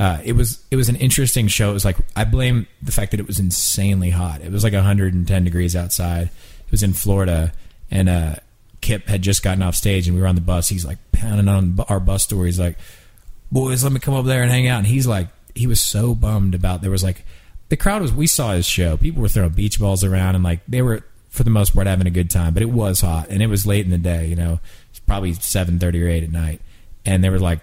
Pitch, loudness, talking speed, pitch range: 95 Hz, -19 LUFS, 265 wpm, 90-110 Hz